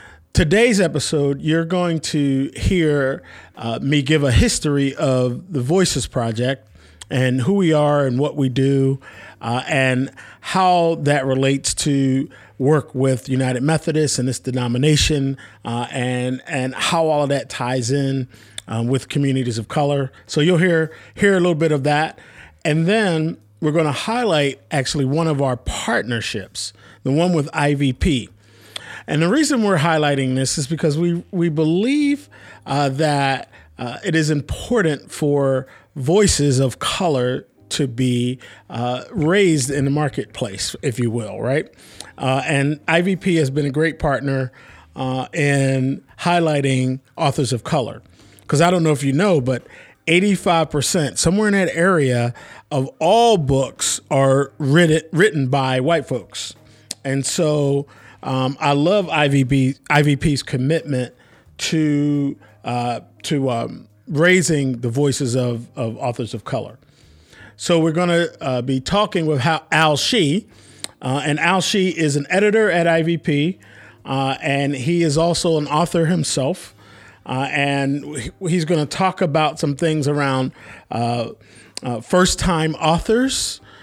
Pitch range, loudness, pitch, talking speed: 130-160 Hz, -19 LUFS, 140 Hz, 145 wpm